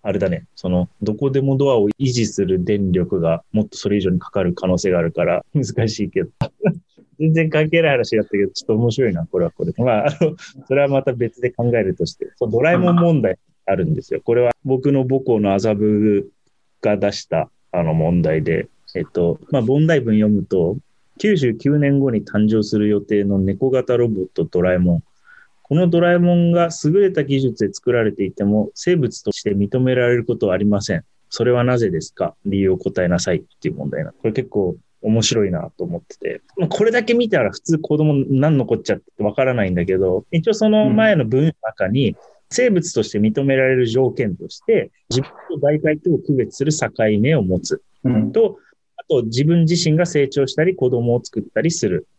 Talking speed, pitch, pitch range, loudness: 365 characters per minute, 130 Hz, 105-160 Hz, -18 LUFS